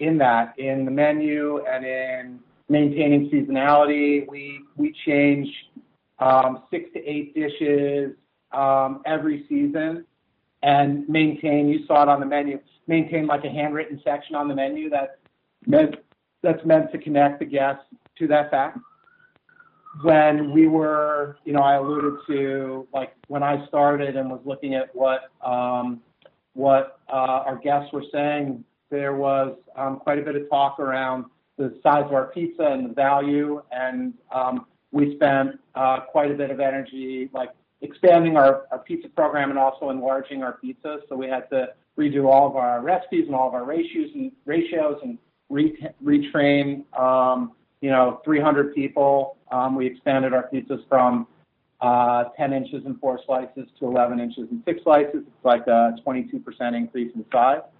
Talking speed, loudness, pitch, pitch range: 165 wpm, -22 LUFS, 140 Hz, 130-150 Hz